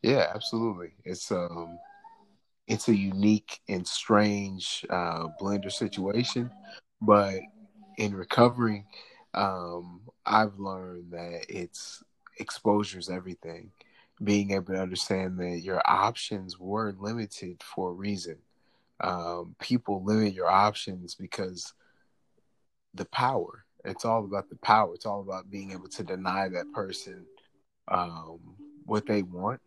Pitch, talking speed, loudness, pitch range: 95 Hz, 120 wpm, -29 LUFS, 90-105 Hz